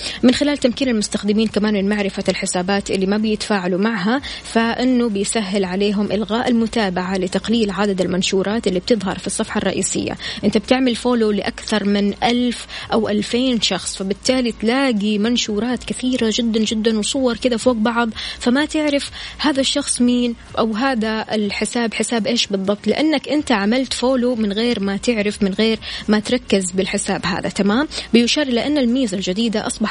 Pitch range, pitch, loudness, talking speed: 205-245 Hz, 220 Hz, -18 LUFS, 155 wpm